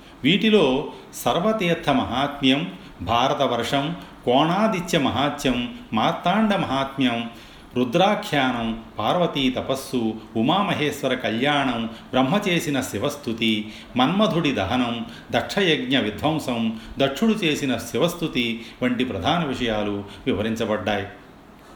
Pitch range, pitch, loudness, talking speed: 115-155 Hz, 130 Hz, -22 LUFS, 70 wpm